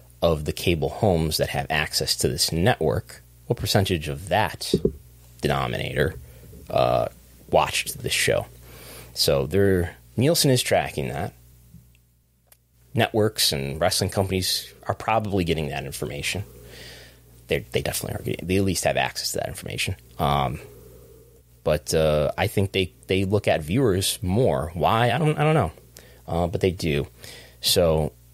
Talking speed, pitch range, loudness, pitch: 145 wpm, 60-95 Hz, -23 LUFS, 75 Hz